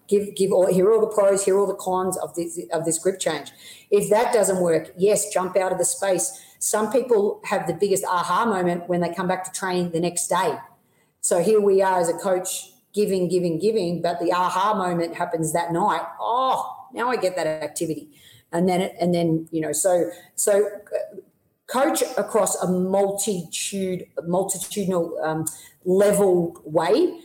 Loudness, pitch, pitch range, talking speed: -22 LUFS, 185 Hz, 175-200 Hz, 180 wpm